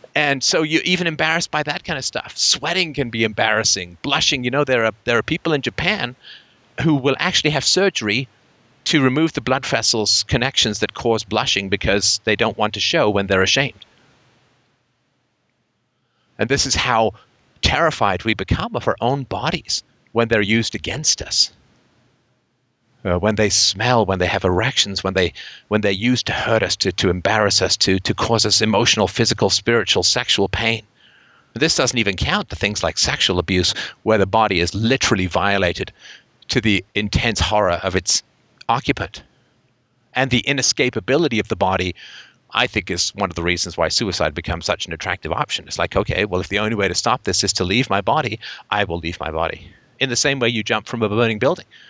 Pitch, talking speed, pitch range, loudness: 110 Hz, 190 wpm, 95-125 Hz, -18 LUFS